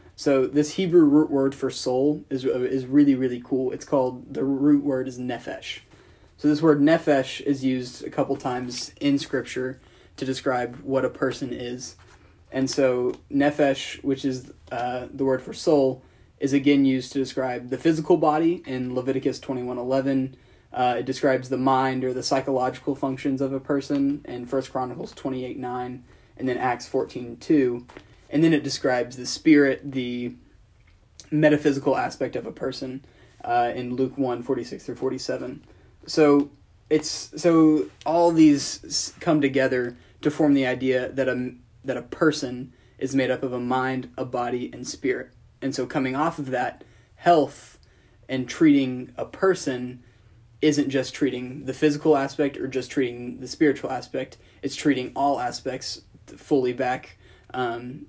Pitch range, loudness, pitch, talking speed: 125-140 Hz, -24 LUFS, 130 Hz, 160 wpm